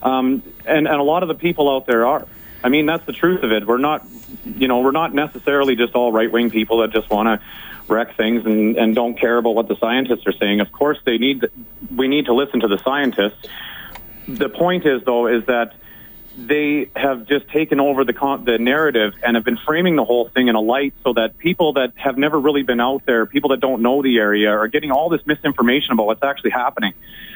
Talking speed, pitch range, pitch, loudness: 235 wpm, 115-145 Hz, 130 Hz, -17 LUFS